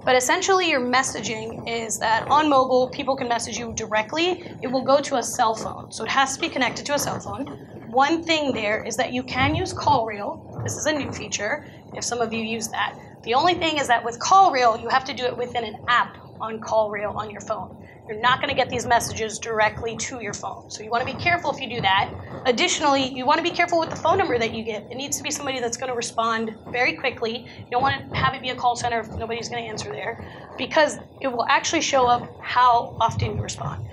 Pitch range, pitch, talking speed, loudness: 230-280 Hz, 250 Hz, 255 wpm, -23 LUFS